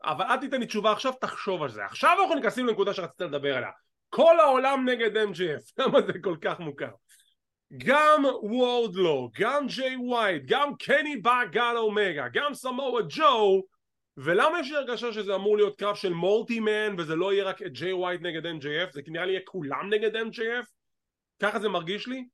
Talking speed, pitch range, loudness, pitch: 180 wpm, 190-260 Hz, -26 LUFS, 220 Hz